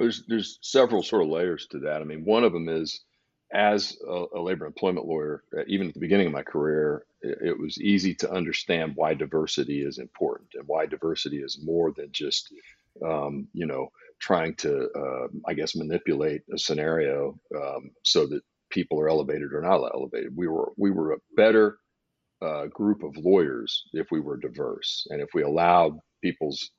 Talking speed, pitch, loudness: 185 wpm, 110 Hz, -26 LUFS